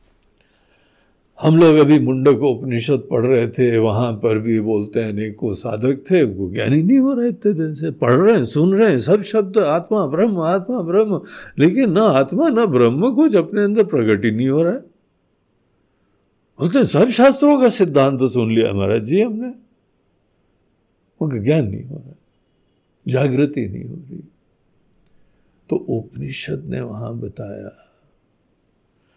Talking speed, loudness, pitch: 150 wpm, -16 LUFS, 140 Hz